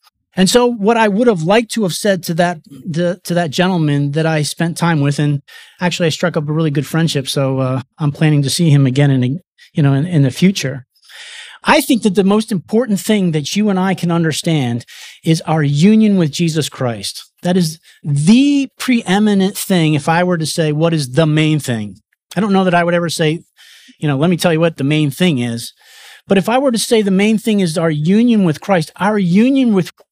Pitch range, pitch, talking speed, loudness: 150-200 Hz, 170 Hz, 230 wpm, -14 LUFS